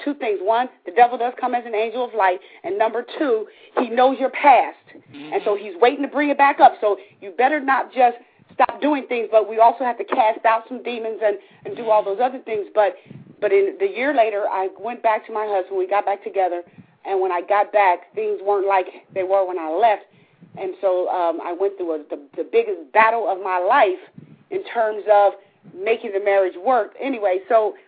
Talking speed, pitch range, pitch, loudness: 225 wpm, 195-255 Hz, 220 Hz, -20 LUFS